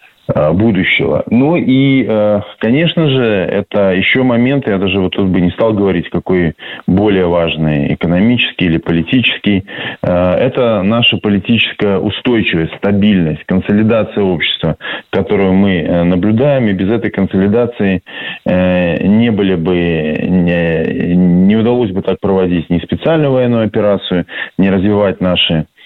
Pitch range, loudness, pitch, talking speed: 90-110 Hz, -12 LUFS, 95 Hz, 120 wpm